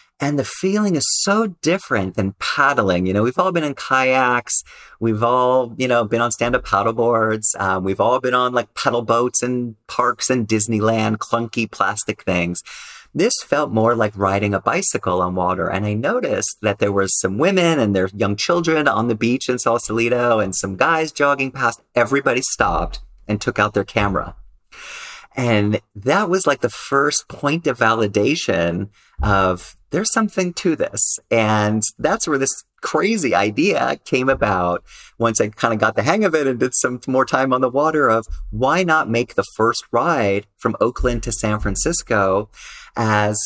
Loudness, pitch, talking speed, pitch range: -18 LUFS, 115 Hz, 180 wpm, 105-130 Hz